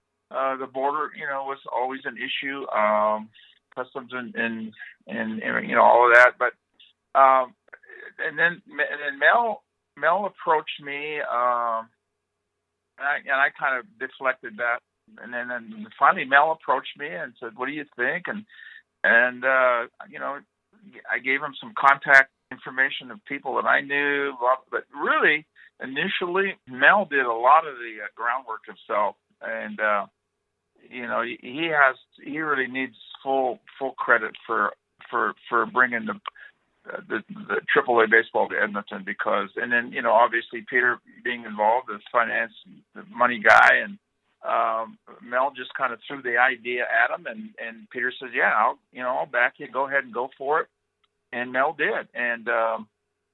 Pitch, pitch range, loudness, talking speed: 130 Hz, 115-140 Hz, -23 LUFS, 170 wpm